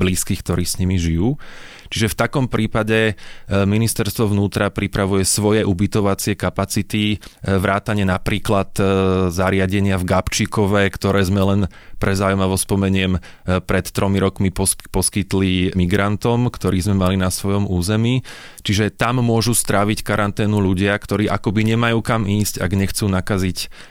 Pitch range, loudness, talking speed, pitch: 95-105 Hz, -18 LUFS, 125 wpm, 100 Hz